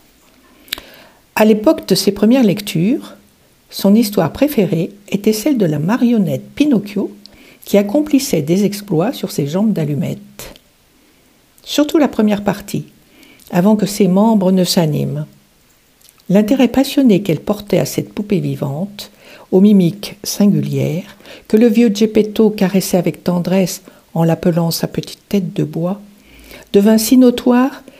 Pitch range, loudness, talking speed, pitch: 180-225 Hz, -15 LUFS, 130 wpm, 205 Hz